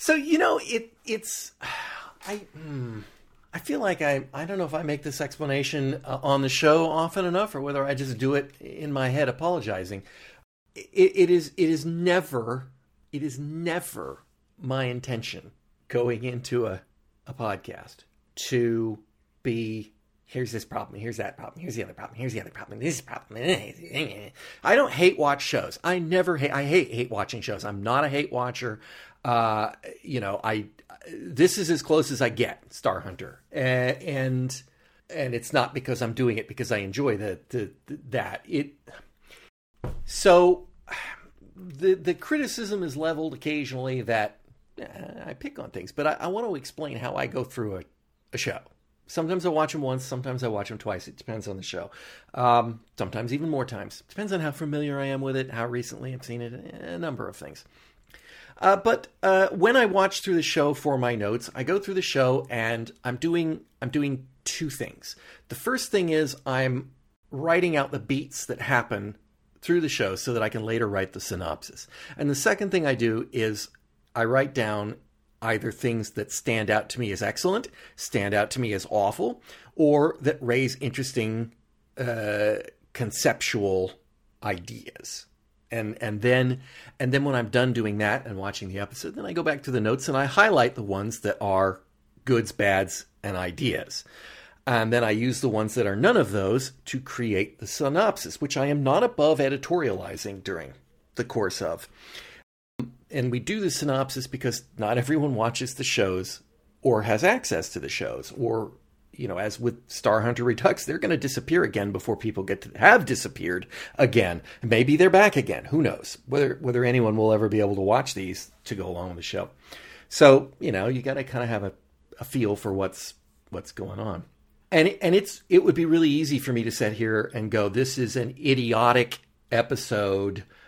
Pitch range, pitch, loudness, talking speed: 110-150 Hz, 125 Hz, -26 LUFS, 185 wpm